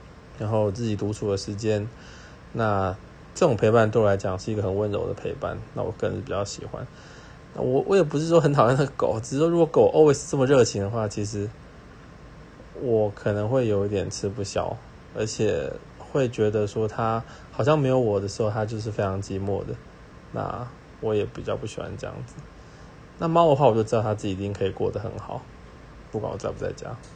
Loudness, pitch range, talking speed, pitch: -25 LUFS, 100-125 Hz, 300 characters per minute, 110 Hz